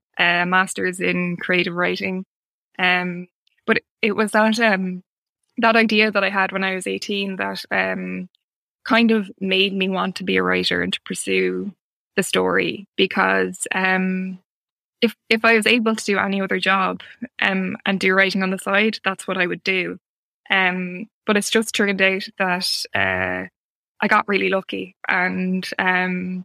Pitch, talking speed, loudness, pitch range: 190 Hz, 170 wpm, -20 LUFS, 180-200 Hz